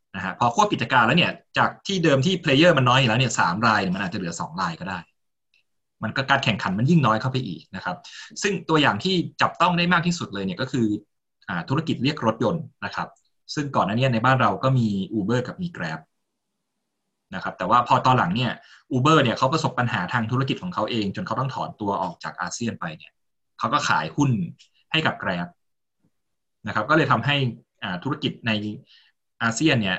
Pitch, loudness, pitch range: 130 Hz, -22 LUFS, 110-155 Hz